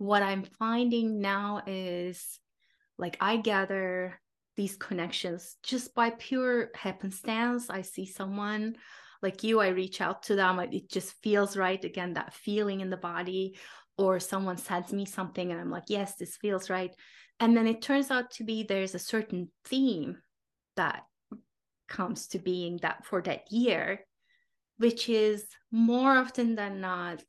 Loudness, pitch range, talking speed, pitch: -31 LUFS, 185-230 Hz, 160 wpm, 200 Hz